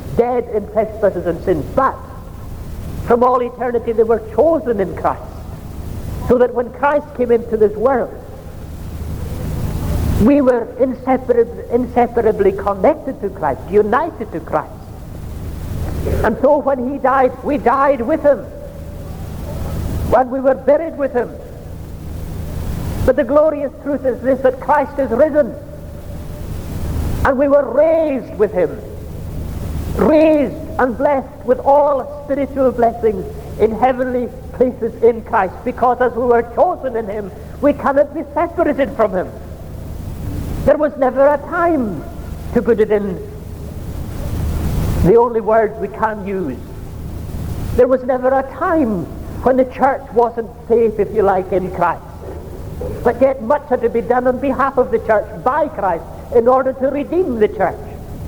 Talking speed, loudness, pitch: 140 wpm, -16 LUFS, 230 Hz